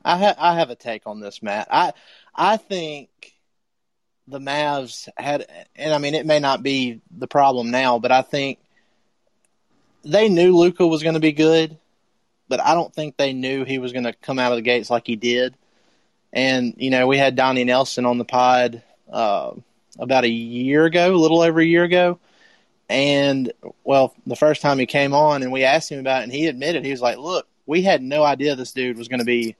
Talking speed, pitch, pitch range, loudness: 215 wpm, 135 Hz, 125-155 Hz, -19 LUFS